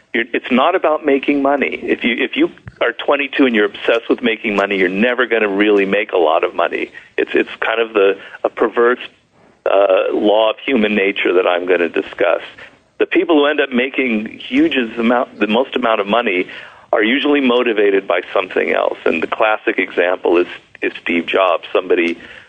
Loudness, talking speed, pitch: -15 LUFS, 190 wpm, 135 Hz